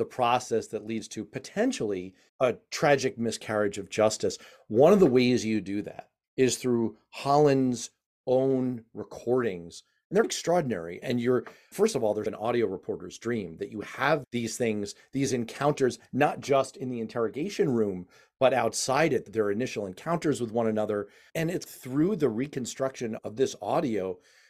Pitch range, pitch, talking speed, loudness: 110-135 Hz, 120 Hz, 160 wpm, -28 LUFS